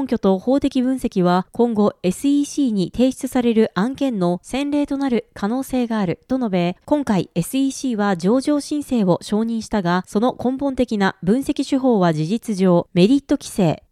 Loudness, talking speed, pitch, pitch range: -19 LUFS, 315 characters per minute, 235 Hz, 195-270 Hz